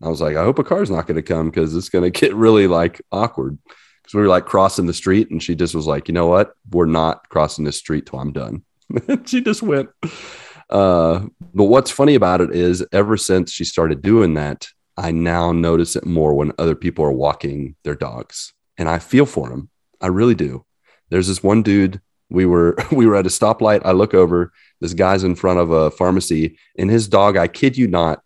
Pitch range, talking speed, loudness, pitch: 80-100 Hz, 225 wpm, -17 LUFS, 90 Hz